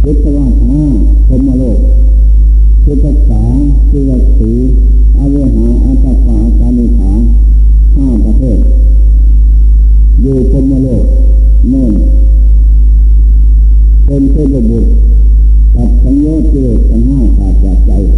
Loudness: -9 LUFS